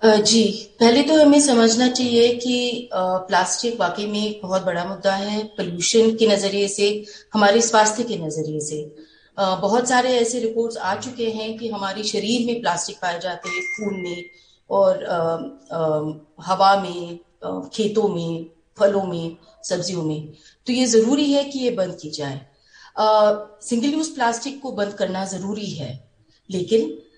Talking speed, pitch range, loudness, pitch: 155 wpm, 175-225 Hz, -20 LUFS, 200 Hz